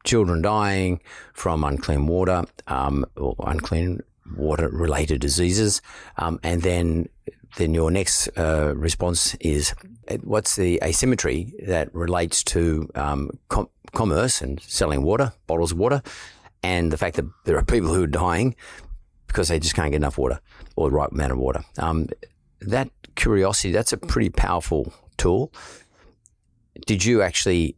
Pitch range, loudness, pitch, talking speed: 75-90 Hz, -23 LUFS, 85 Hz, 150 wpm